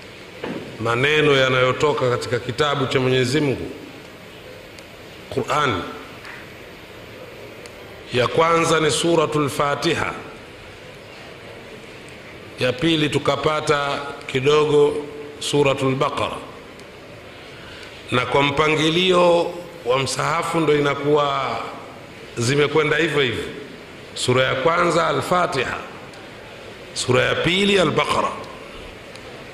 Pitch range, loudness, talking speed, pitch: 135-160 Hz, -19 LUFS, 75 wpm, 145 Hz